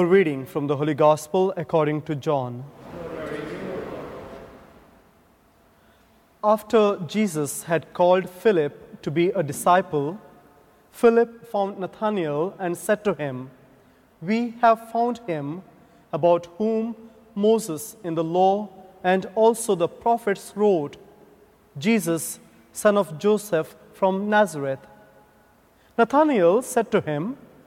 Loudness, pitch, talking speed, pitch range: -23 LUFS, 190 Hz, 105 wpm, 160-220 Hz